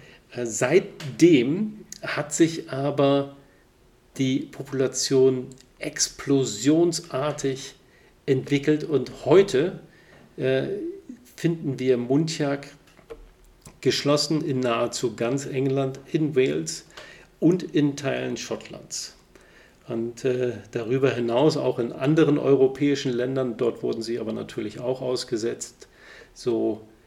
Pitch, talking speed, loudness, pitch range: 135 Hz, 90 wpm, -24 LUFS, 125-150 Hz